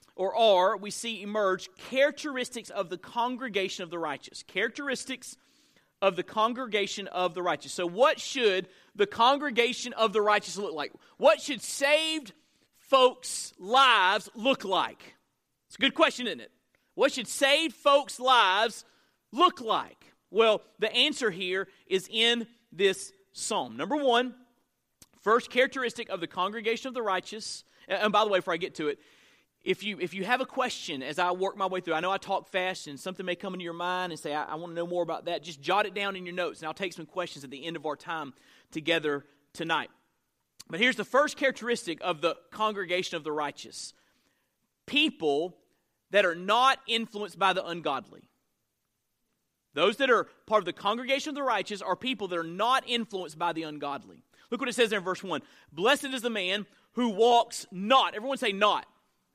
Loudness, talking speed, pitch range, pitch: -28 LUFS, 190 wpm, 180-250 Hz, 205 Hz